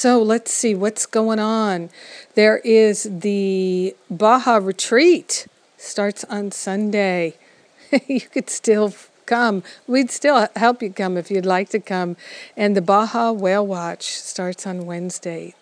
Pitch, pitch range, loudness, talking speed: 210 Hz, 190-225 Hz, -19 LUFS, 140 wpm